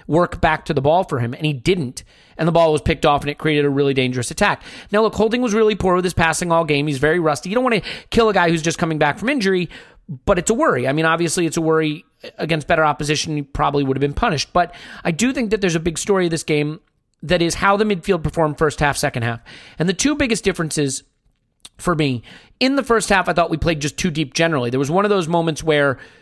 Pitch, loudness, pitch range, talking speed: 165 Hz, -18 LUFS, 150-185 Hz, 270 wpm